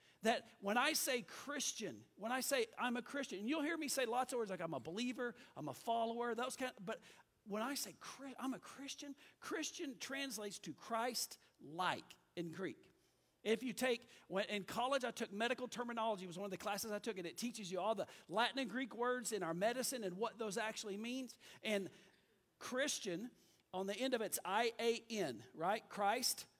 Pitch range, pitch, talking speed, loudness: 210-255 Hz, 235 Hz, 205 wpm, -42 LUFS